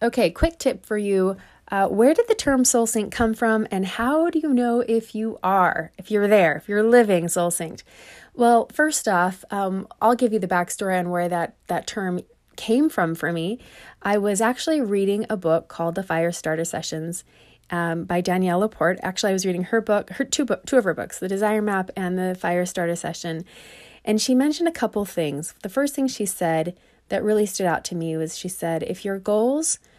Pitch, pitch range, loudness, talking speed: 200 Hz, 175-230 Hz, -22 LUFS, 215 wpm